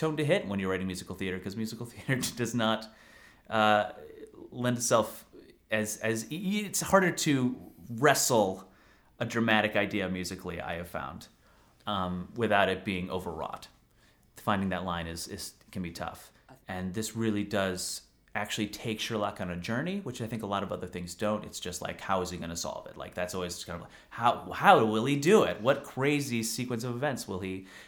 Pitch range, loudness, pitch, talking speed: 95-120 Hz, -30 LUFS, 105 Hz, 195 wpm